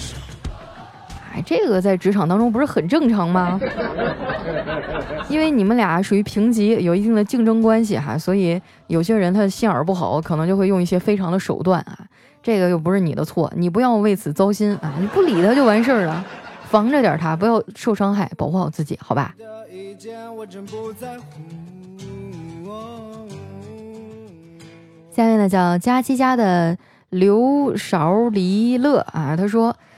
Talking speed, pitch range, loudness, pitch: 220 characters per minute, 170-225 Hz, -18 LUFS, 195 Hz